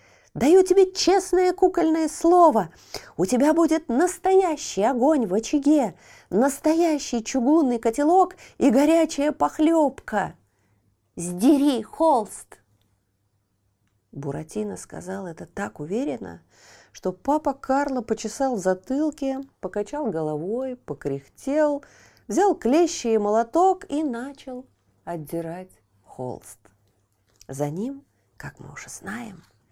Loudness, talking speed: -22 LUFS, 95 wpm